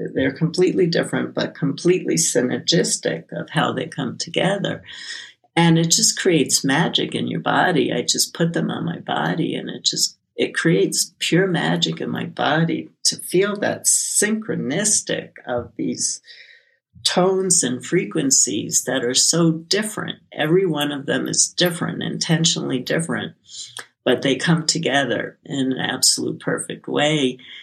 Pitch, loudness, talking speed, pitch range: 165 Hz, -19 LUFS, 145 wpm, 135-180 Hz